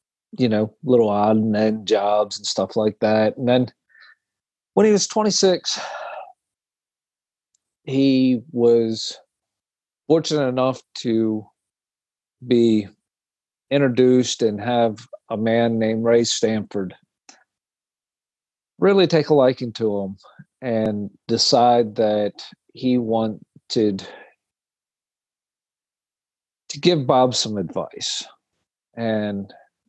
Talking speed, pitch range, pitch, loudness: 95 wpm, 110-130 Hz, 115 Hz, -20 LUFS